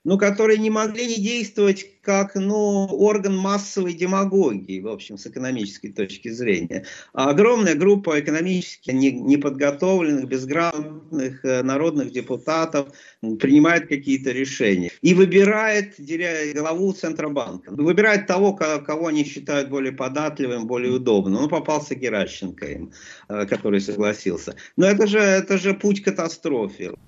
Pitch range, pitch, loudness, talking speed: 130-195 Hz, 155 Hz, -21 LUFS, 125 wpm